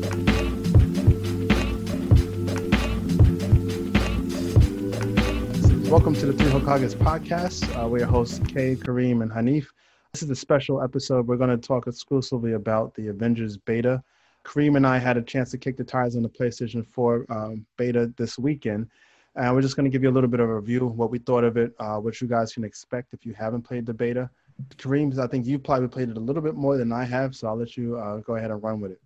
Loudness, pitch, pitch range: -24 LUFS, 120 Hz, 110-130 Hz